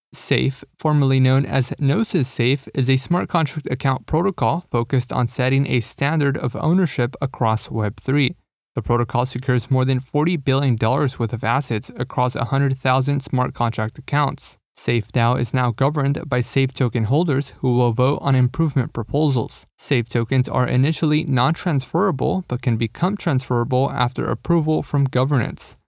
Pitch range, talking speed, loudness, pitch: 125-145 Hz, 145 wpm, -20 LUFS, 130 Hz